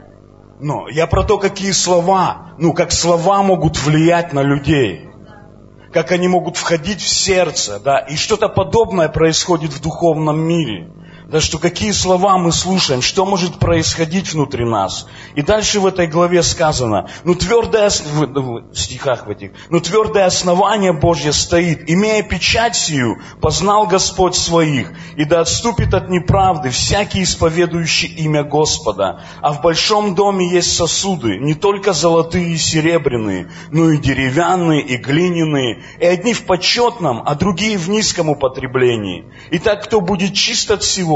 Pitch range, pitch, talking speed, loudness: 145-185 Hz, 170 Hz, 150 wpm, -15 LUFS